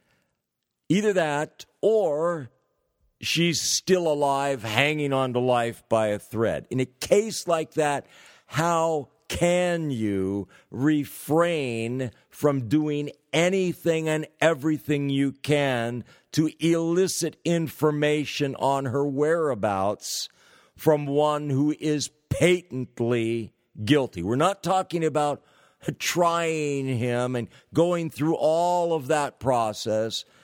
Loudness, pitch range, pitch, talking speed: -25 LUFS, 130-165 Hz, 145 Hz, 105 wpm